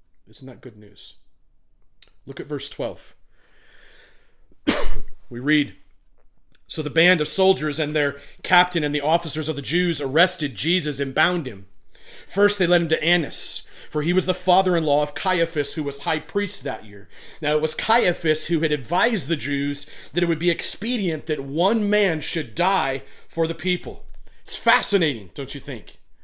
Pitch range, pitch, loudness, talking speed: 140-180 Hz, 155 Hz, -21 LUFS, 175 wpm